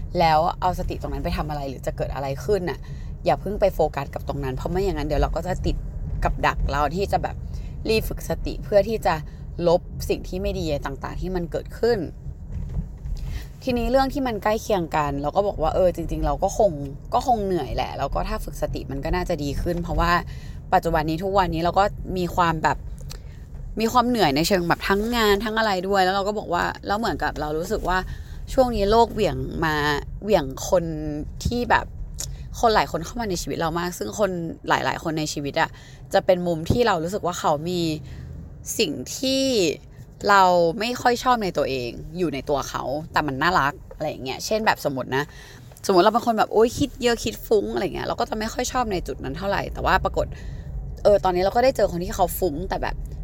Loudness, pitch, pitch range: -23 LUFS, 175 Hz, 150-205 Hz